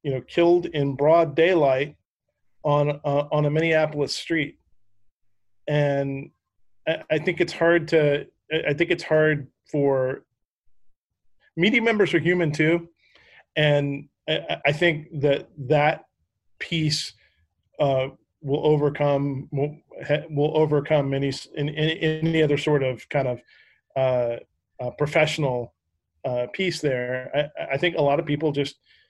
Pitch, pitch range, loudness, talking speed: 145 Hz, 135-155 Hz, -23 LUFS, 130 wpm